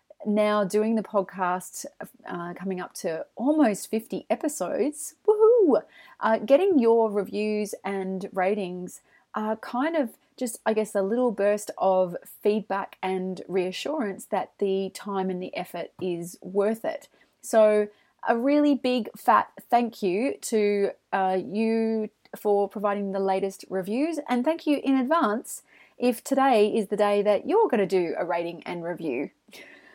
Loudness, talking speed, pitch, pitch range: -26 LUFS, 150 wpm, 210 Hz, 190-245 Hz